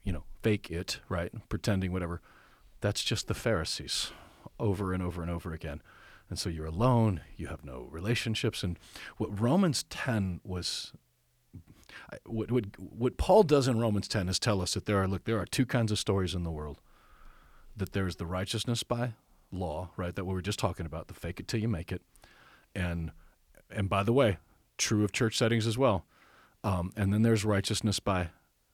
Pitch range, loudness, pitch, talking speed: 85-110 Hz, -31 LUFS, 100 Hz, 190 wpm